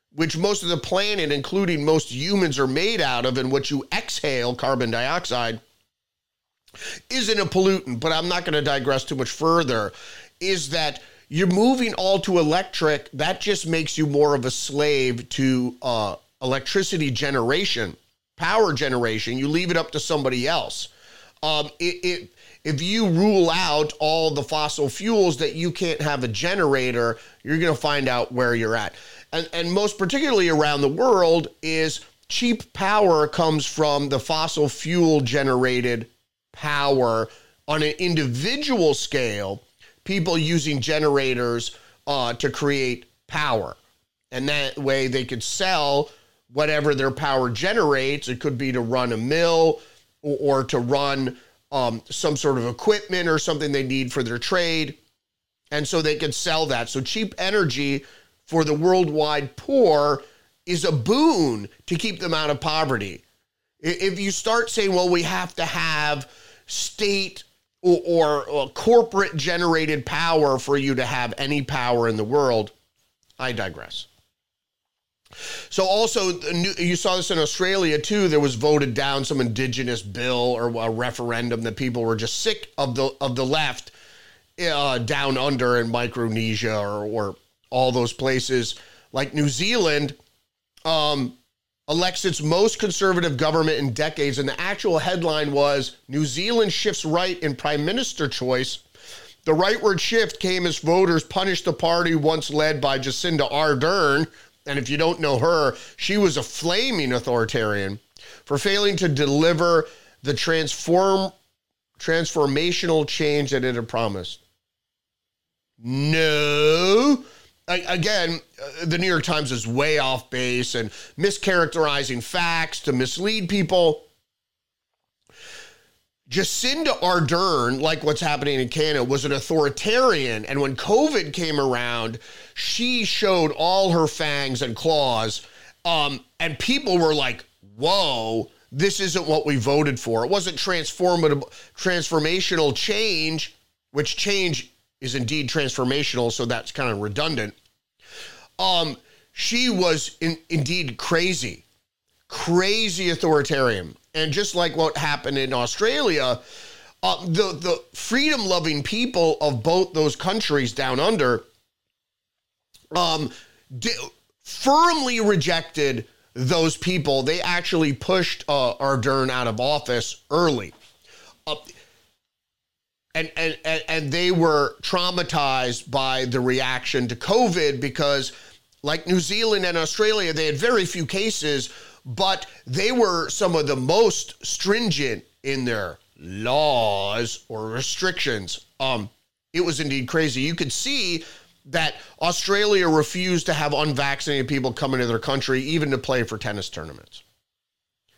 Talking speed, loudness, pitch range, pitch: 140 wpm, -22 LUFS, 130-175 Hz, 150 Hz